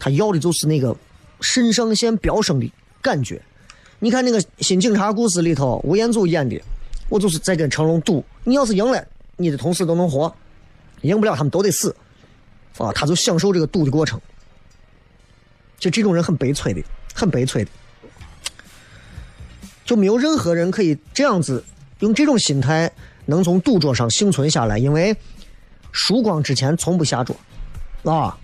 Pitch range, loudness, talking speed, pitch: 135-200 Hz, -19 LUFS, 250 characters per minute, 165 Hz